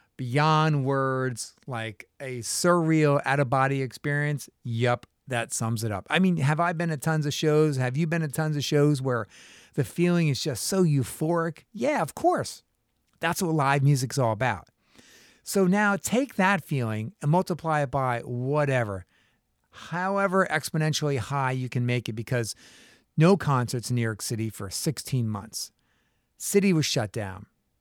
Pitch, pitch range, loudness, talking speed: 140 Hz, 120-160 Hz, -26 LUFS, 160 wpm